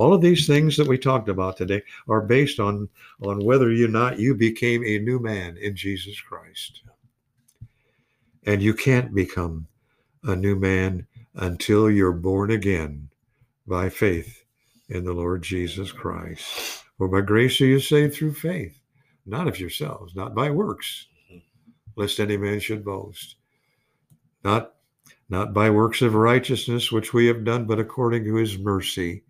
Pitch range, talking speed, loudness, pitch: 95-125 Hz, 155 wpm, -22 LUFS, 110 Hz